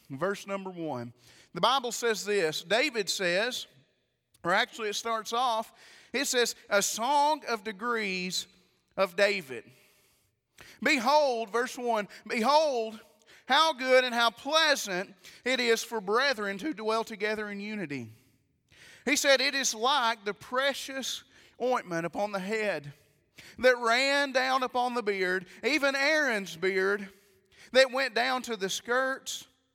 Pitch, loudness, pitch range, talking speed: 225 Hz, -28 LUFS, 195-255 Hz, 135 wpm